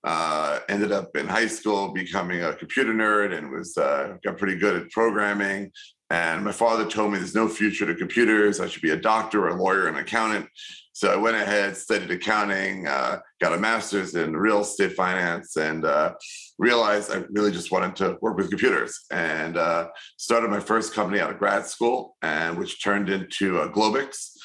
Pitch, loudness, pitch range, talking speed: 100 Hz, -24 LUFS, 95-110 Hz, 195 wpm